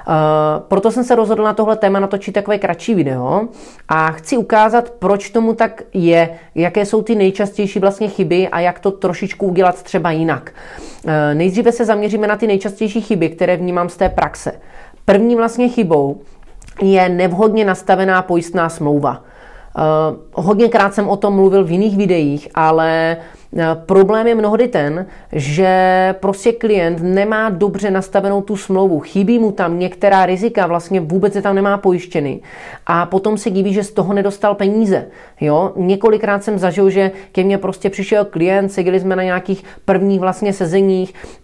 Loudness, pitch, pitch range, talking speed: -15 LUFS, 195 Hz, 180-210 Hz, 160 wpm